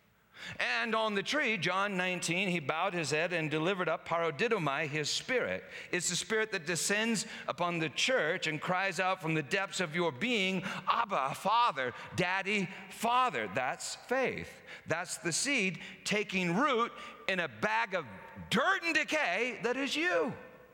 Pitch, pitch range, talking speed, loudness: 190 Hz, 175-225 Hz, 155 wpm, -32 LUFS